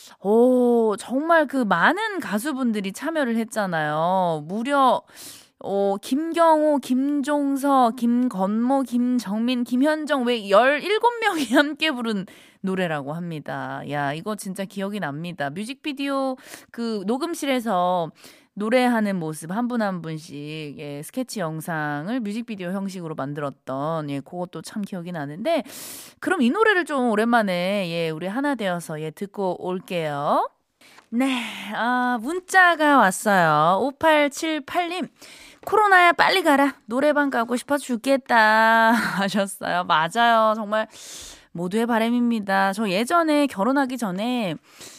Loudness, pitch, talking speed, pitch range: -22 LUFS, 230 Hz, 260 characters per minute, 185-280 Hz